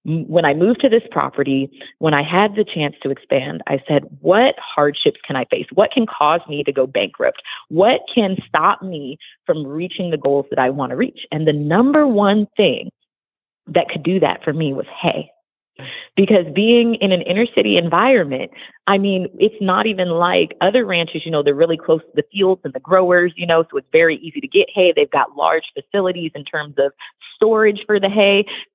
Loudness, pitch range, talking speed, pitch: -17 LUFS, 155-210 Hz, 205 wpm, 180 Hz